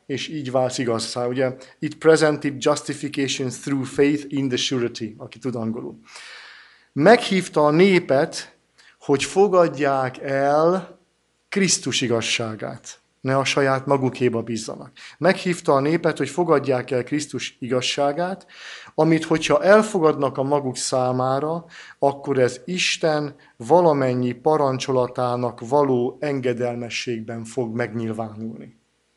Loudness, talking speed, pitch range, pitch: -21 LUFS, 105 wpm, 125-155 Hz, 135 Hz